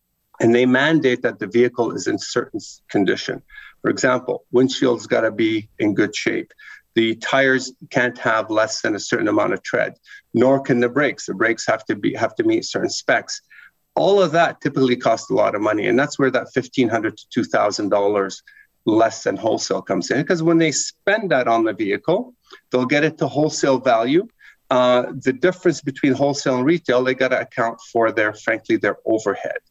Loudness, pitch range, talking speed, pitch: -19 LUFS, 120-160 Hz, 195 wpm, 130 Hz